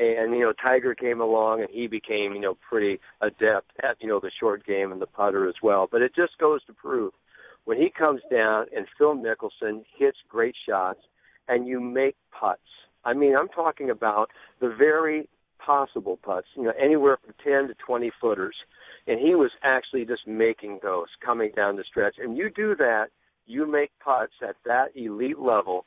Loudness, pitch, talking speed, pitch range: -25 LUFS, 125 Hz, 195 wpm, 110-150 Hz